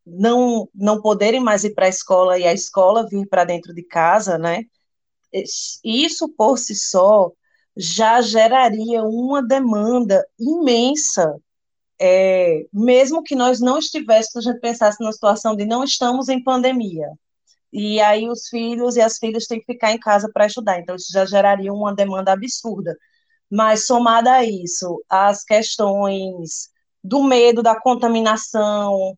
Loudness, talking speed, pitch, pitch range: -17 LUFS, 150 wpm, 220 Hz, 195-245 Hz